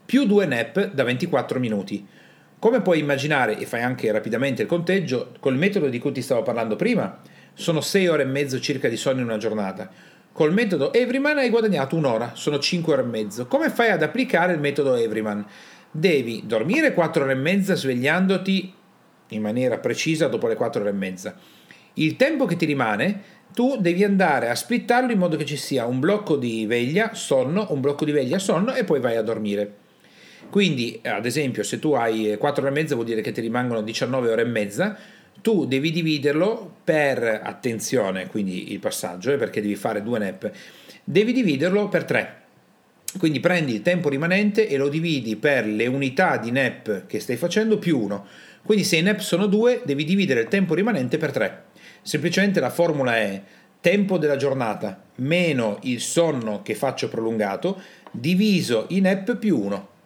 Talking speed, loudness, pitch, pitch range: 185 wpm, -22 LUFS, 155 Hz, 125-195 Hz